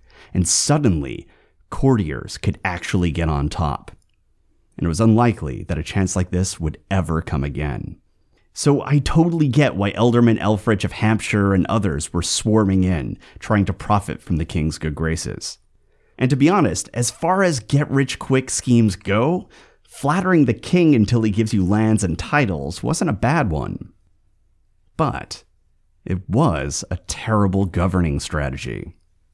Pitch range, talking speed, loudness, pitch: 85-115 Hz, 155 wpm, -20 LUFS, 100 Hz